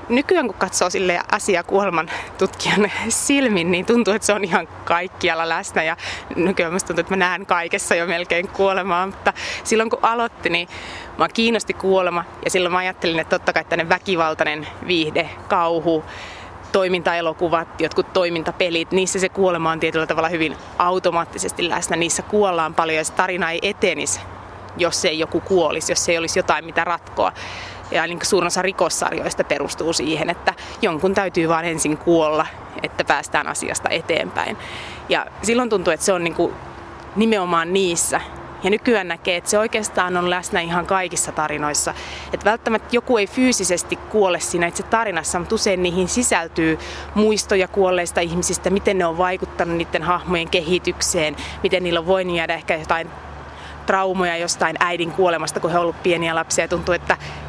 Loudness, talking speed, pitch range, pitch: -20 LUFS, 160 wpm, 165-190 Hz, 175 Hz